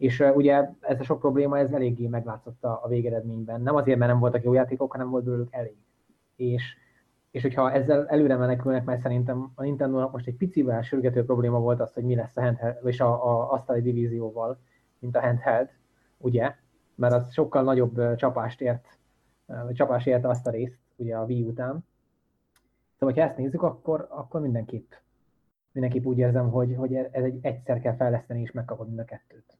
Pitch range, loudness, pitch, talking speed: 120-130 Hz, -26 LUFS, 125 Hz, 180 wpm